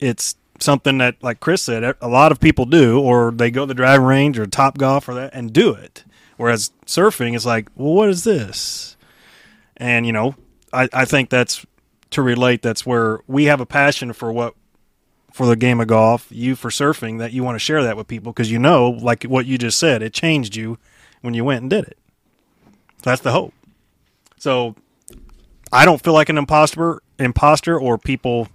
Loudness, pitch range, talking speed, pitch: -16 LUFS, 120-140 Hz, 205 wpm, 125 Hz